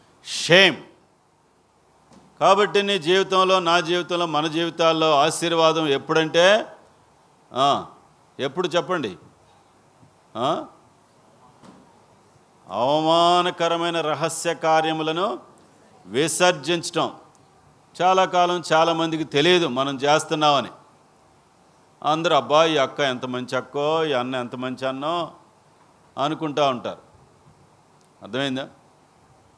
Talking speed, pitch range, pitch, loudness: 75 wpm, 145-175 Hz, 160 Hz, -21 LUFS